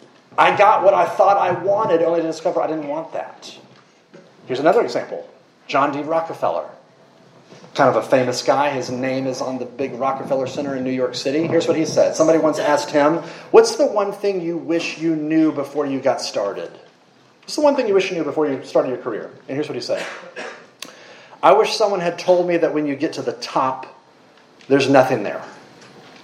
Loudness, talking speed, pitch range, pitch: -19 LUFS, 210 wpm, 140-180 Hz, 160 Hz